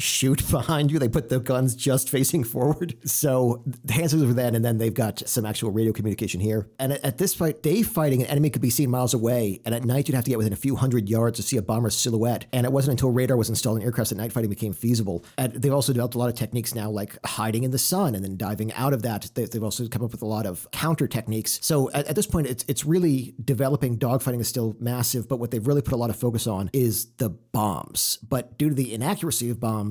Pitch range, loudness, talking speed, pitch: 115-135 Hz, -24 LUFS, 265 wpm, 125 Hz